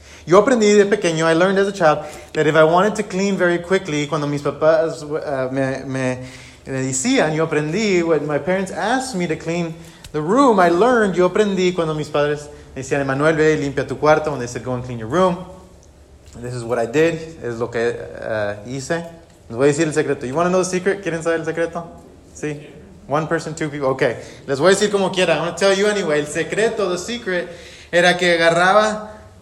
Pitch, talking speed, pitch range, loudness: 160 Hz, 225 wpm, 140-180 Hz, -18 LUFS